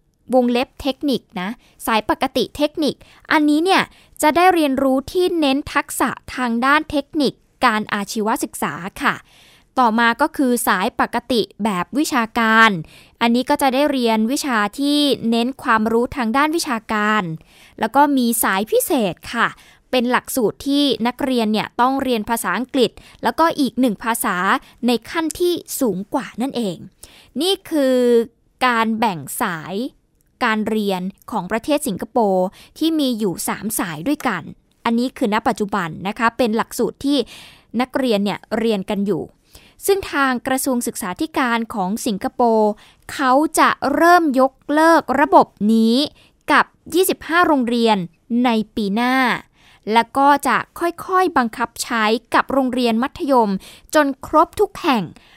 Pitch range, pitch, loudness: 225-285 Hz, 250 Hz, -18 LUFS